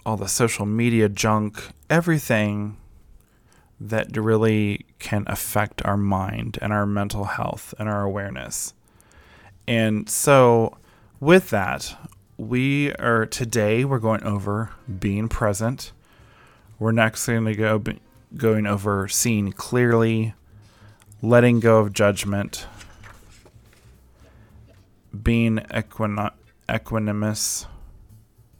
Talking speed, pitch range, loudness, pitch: 100 wpm, 100-115 Hz, -22 LUFS, 110 Hz